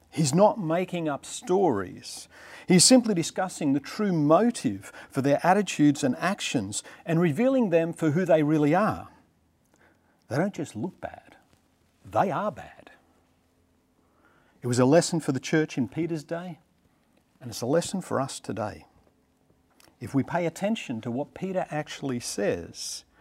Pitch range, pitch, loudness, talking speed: 135-180 Hz, 160 Hz, -26 LUFS, 150 wpm